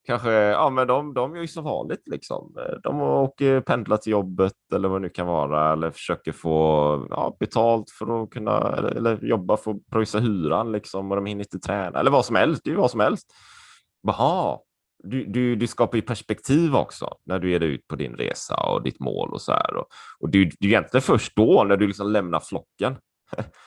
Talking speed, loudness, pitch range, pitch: 225 wpm, -23 LUFS, 95-120 Hz, 105 Hz